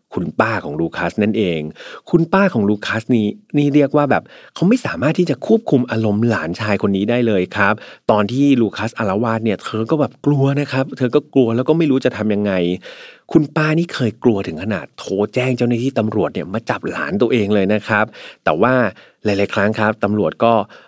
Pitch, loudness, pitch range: 115 Hz, -17 LUFS, 105-140 Hz